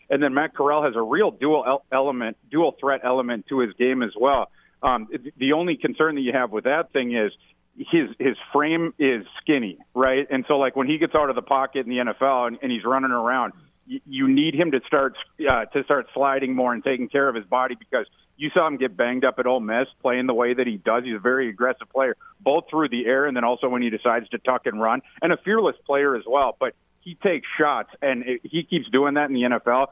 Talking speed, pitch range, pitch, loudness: 245 wpm, 125-150 Hz, 135 Hz, -22 LUFS